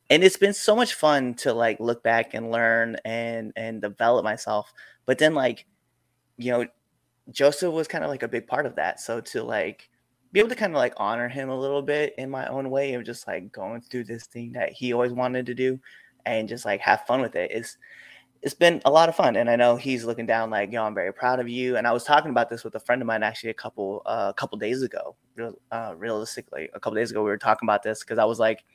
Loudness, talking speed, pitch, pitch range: -25 LUFS, 260 wpm, 120 Hz, 115-130 Hz